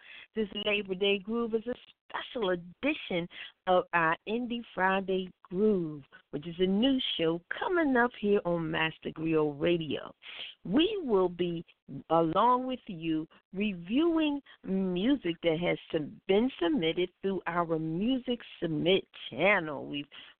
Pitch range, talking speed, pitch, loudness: 170-230 Hz, 125 wpm, 185 Hz, -30 LUFS